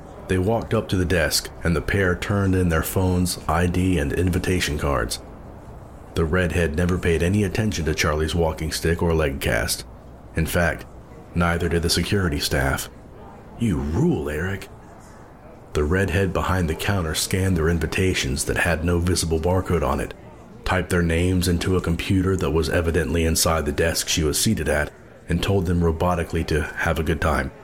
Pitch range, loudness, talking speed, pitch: 80-90 Hz, -22 LUFS, 175 wpm, 85 Hz